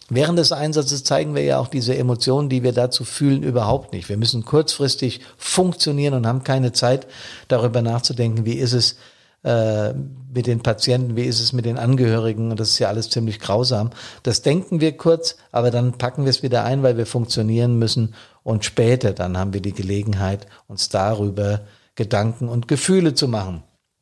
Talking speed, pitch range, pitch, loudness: 185 wpm, 110-130 Hz, 120 Hz, -20 LUFS